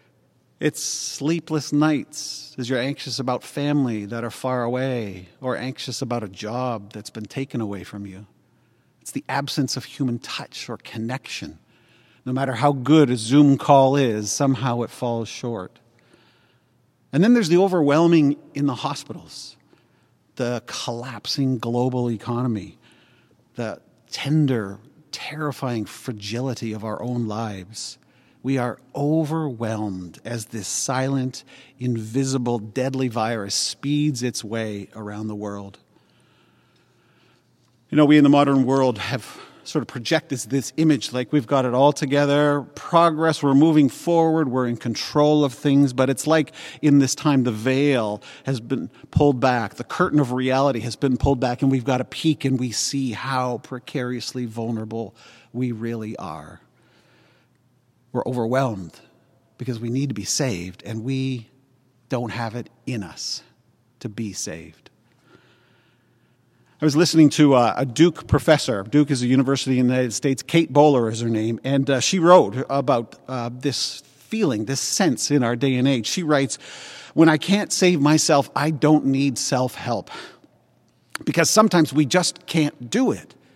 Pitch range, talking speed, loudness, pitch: 120-145 Hz, 150 wpm, -21 LUFS, 130 Hz